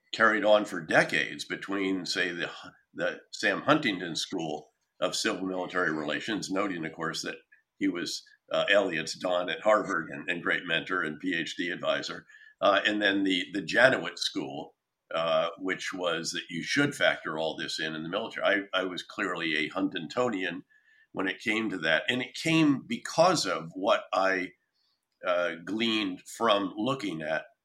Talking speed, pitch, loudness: 165 wpm, 125 Hz, -29 LUFS